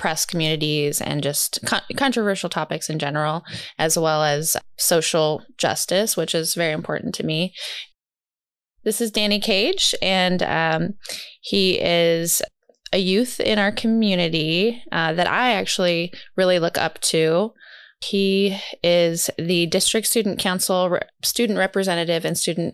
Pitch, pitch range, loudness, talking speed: 175 Hz, 160-200 Hz, -20 LUFS, 135 wpm